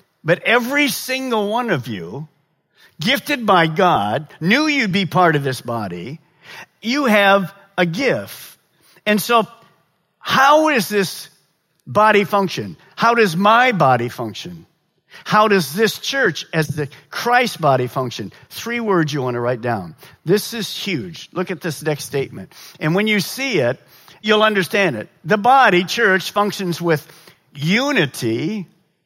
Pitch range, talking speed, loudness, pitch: 155-215 Hz, 145 wpm, -17 LUFS, 185 Hz